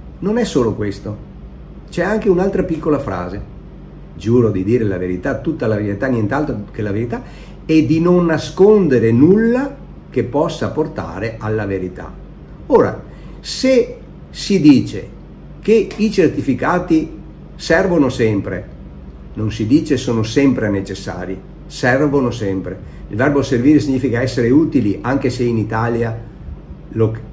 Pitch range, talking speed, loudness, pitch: 105-155 Hz, 130 wpm, -16 LUFS, 120 Hz